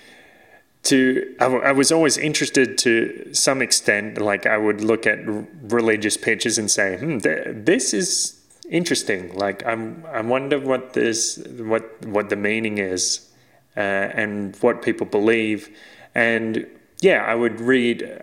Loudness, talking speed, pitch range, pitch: -20 LUFS, 150 wpm, 105-125 Hz, 115 Hz